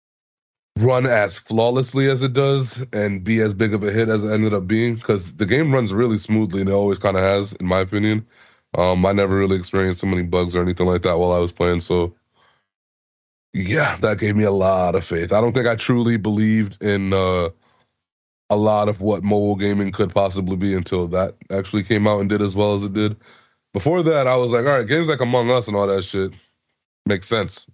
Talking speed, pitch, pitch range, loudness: 225 wpm, 105 Hz, 95-115 Hz, -19 LUFS